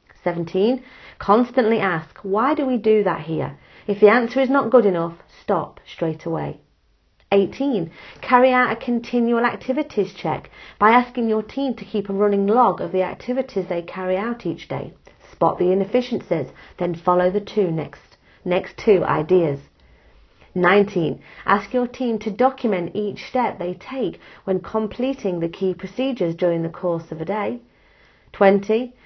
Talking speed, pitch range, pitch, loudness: 155 wpm, 180-240 Hz, 200 Hz, -21 LUFS